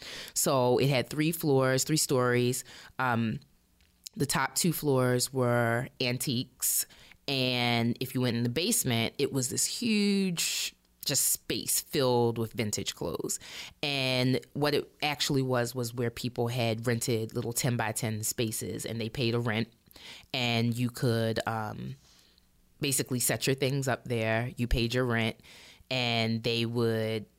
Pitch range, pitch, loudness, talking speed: 115-130 Hz, 120 Hz, -29 LUFS, 150 wpm